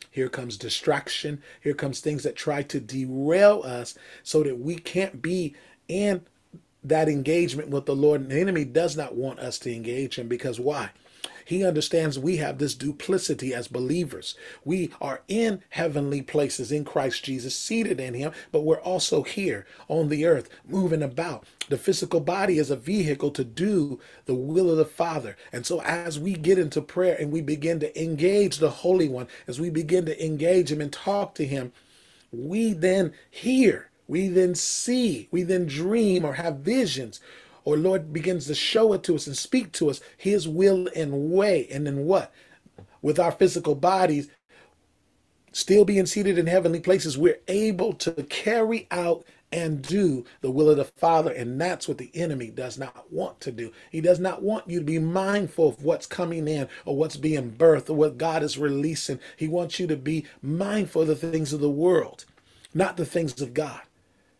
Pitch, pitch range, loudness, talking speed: 160 Hz, 145-180 Hz, -25 LUFS, 185 wpm